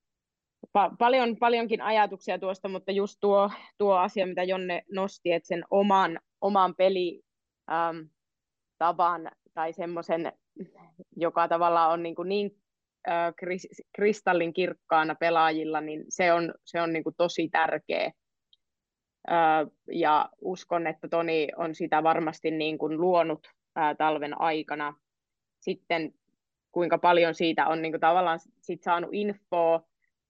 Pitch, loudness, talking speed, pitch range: 170 Hz, -27 LUFS, 120 wpm, 160-190 Hz